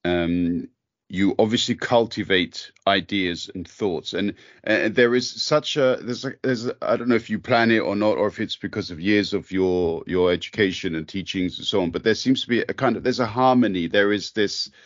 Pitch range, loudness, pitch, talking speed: 95-120 Hz, -22 LUFS, 105 Hz, 220 wpm